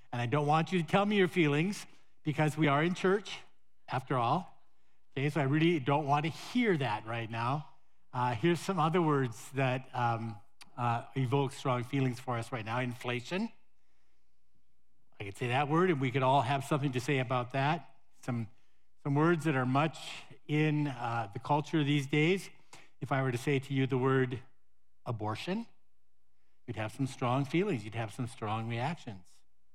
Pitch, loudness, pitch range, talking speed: 135 Hz, -32 LUFS, 120-155 Hz, 185 wpm